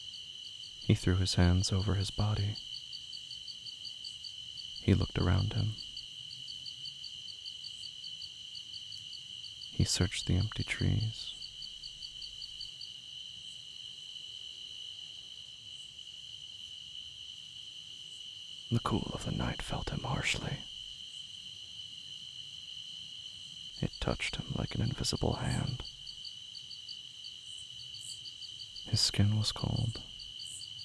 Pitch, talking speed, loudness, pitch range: 110 Hz, 70 wpm, -37 LUFS, 105-120 Hz